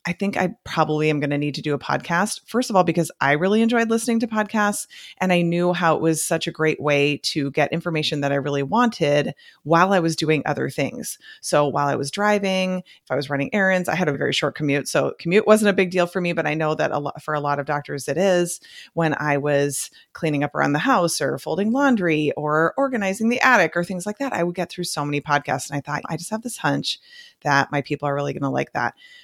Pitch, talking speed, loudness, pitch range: 165 Hz, 255 wpm, -21 LUFS, 145-195 Hz